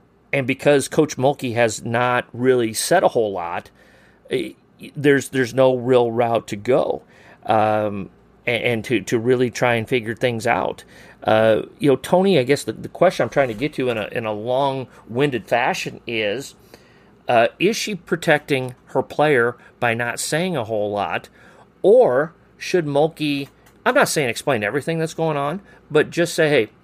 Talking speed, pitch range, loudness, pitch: 175 wpm, 120-150 Hz, -20 LUFS, 130 Hz